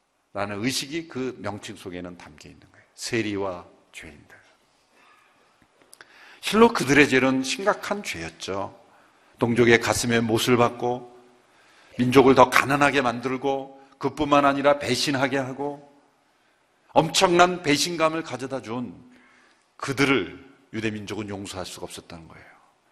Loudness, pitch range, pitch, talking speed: -22 LUFS, 110-145 Hz, 125 Hz, 265 characters per minute